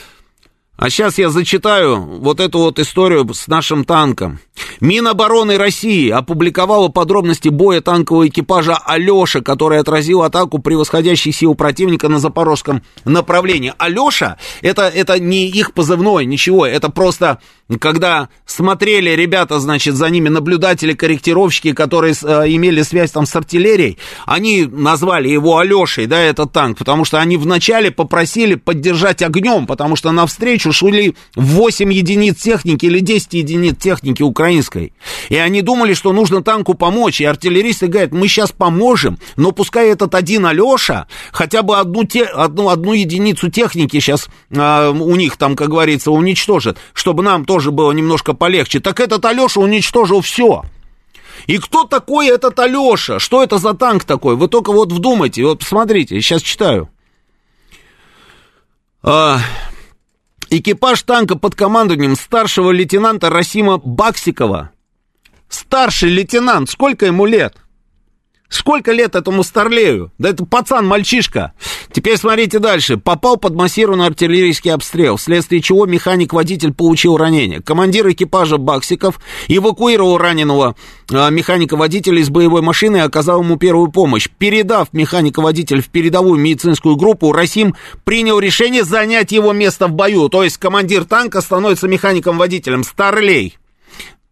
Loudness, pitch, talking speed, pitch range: -12 LUFS, 180 Hz, 135 wpm, 160-205 Hz